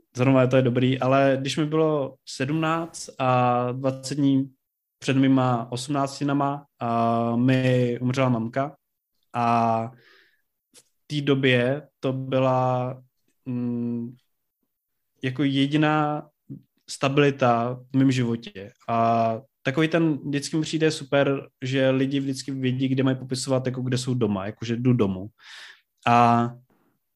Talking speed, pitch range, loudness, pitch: 115 wpm, 120-140 Hz, -24 LUFS, 130 Hz